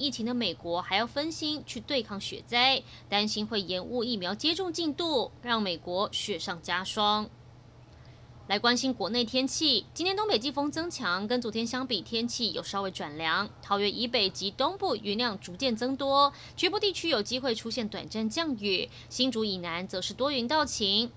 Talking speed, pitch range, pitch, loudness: 270 characters per minute, 200-275 Hz, 235 Hz, -29 LUFS